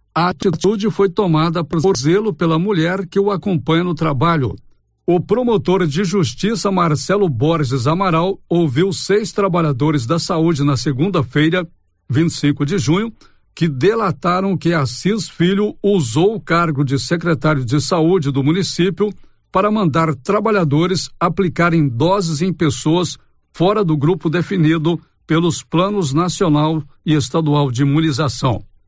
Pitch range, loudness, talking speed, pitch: 155-190 Hz, -17 LUFS, 130 wpm, 170 Hz